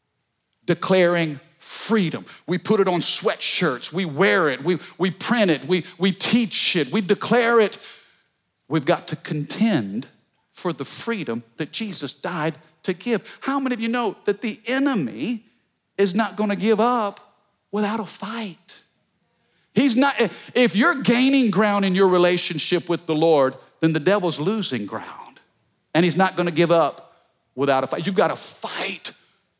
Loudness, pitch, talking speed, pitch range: -21 LUFS, 190 Hz, 165 wpm, 165-225 Hz